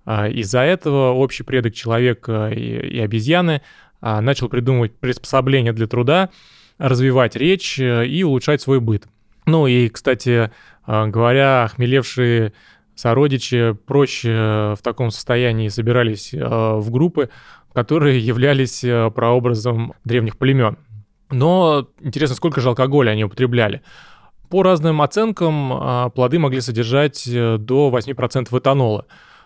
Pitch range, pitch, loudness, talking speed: 115-140 Hz, 125 Hz, -17 LUFS, 105 wpm